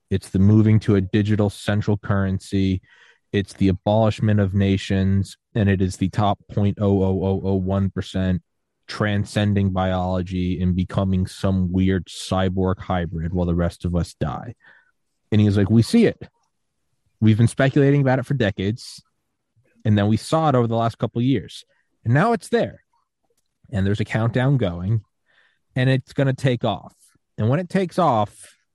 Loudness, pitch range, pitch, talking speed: -21 LUFS, 95-115 Hz, 100 Hz, 175 wpm